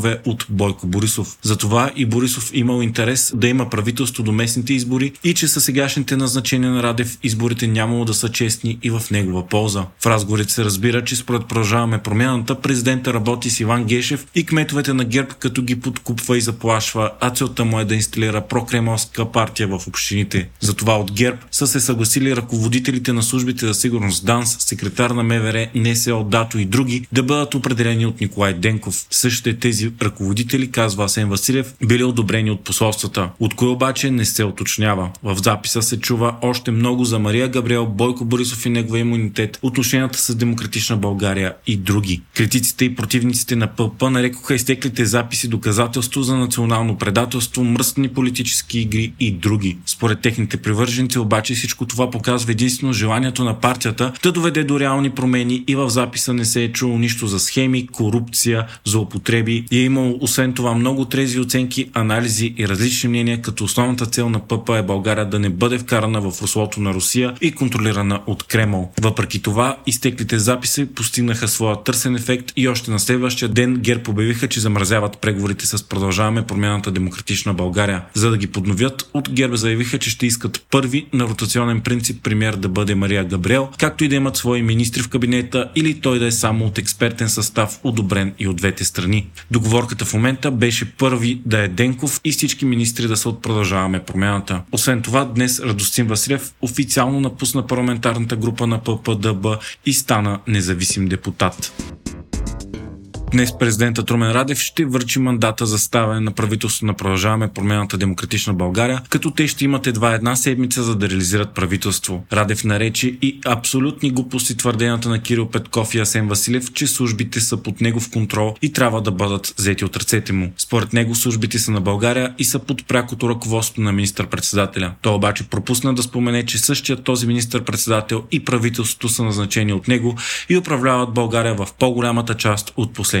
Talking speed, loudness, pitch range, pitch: 175 wpm, -18 LUFS, 110-125 Hz, 120 Hz